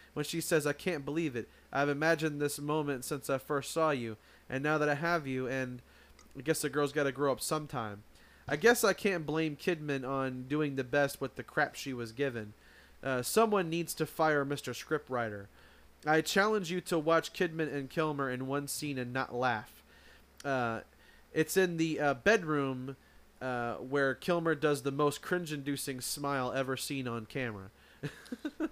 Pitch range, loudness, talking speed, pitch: 130-160 Hz, -33 LUFS, 185 wpm, 145 Hz